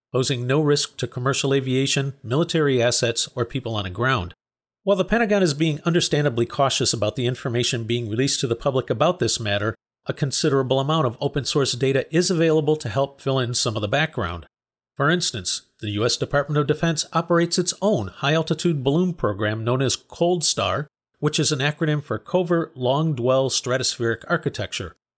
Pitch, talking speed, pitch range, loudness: 135 Hz, 180 wpm, 120-155 Hz, -21 LUFS